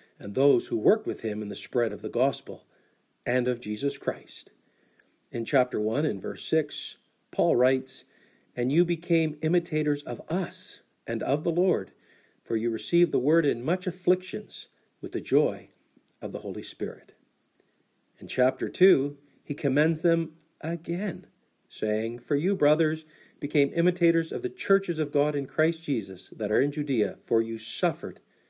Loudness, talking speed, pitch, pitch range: -27 LUFS, 160 wpm, 150 Hz, 125-170 Hz